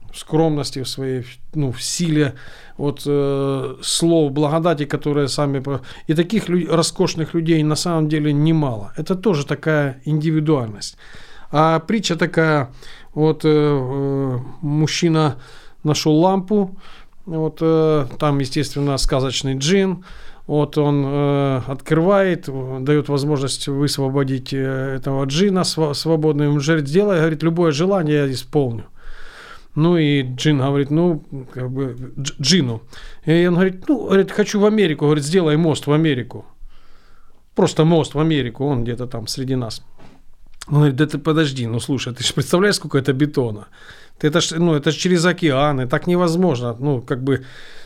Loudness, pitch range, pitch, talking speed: -18 LUFS, 135-165 Hz, 150 Hz, 145 wpm